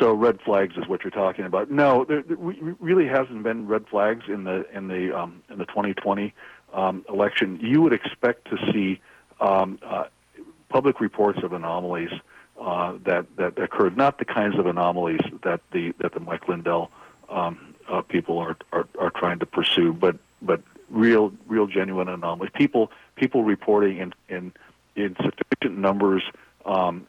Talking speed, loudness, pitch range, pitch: 170 wpm, -24 LUFS, 95-110 Hz, 100 Hz